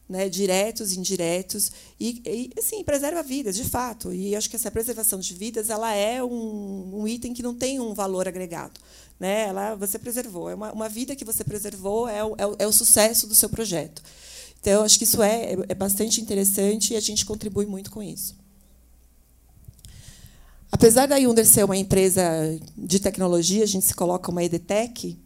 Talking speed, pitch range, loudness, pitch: 190 wpm, 185-225 Hz, -22 LUFS, 210 Hz